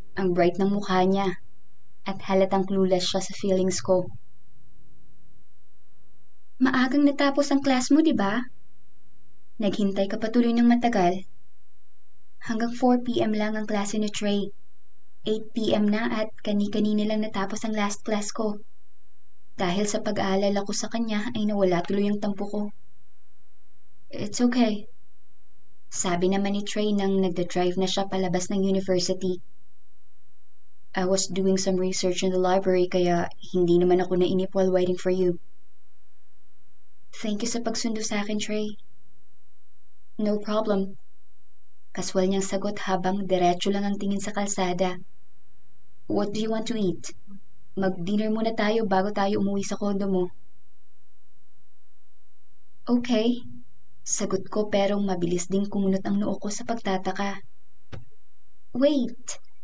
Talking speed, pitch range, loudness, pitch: 135 wpm, 185-210 Hz, -25 LUFS, 195 Hz